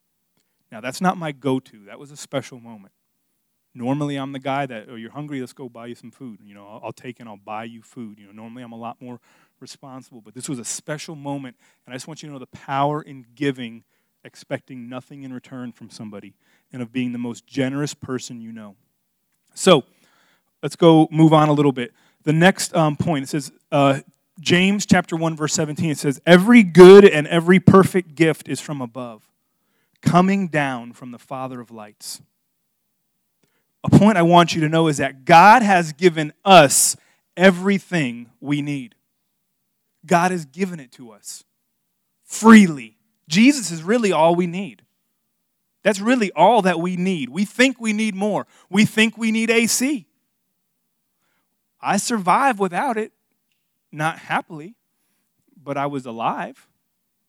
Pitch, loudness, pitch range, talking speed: 155 Hz, -17 LUFS, 130-195 Hz, 175 wpm